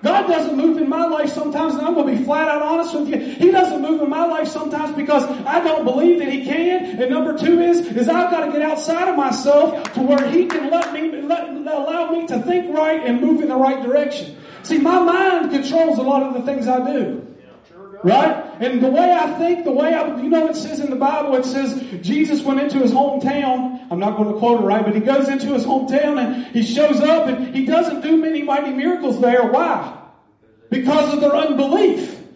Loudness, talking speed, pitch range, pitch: -17 LUFS, 230 wpm, 265-320 Hz, 295 Hz